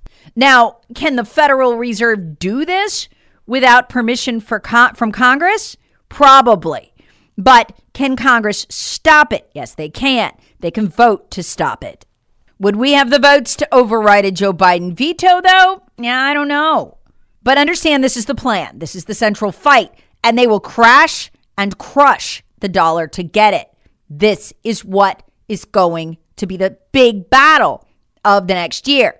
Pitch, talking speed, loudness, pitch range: 235 Hz, 165 wpm, -12 LUFS, 200-275 Hz